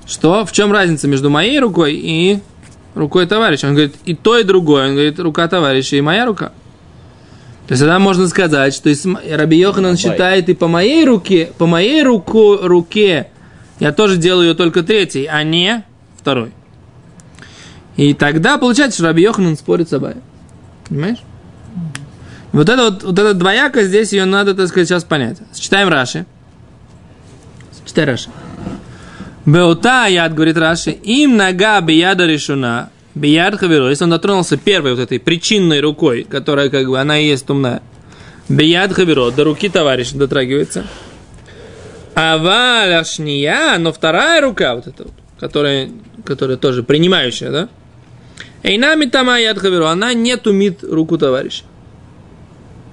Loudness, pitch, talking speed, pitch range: -12 LUFS, 170 Hz, 145 wpm, 145-200 Hz